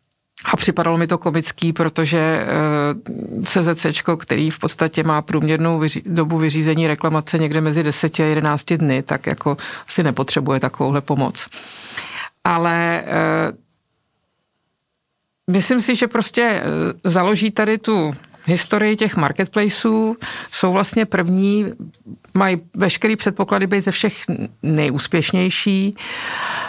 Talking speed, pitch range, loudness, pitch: 110 wpm, 155-205 Hz, -18 LUFS, 170 Hz